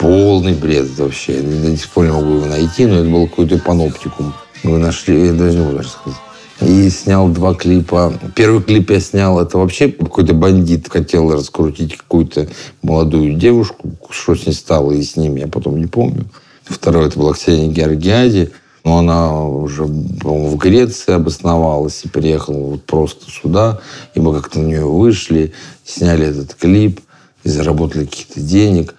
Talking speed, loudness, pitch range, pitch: 165 wpm, -13 LUFS, 75-90 Hz, 85 Hz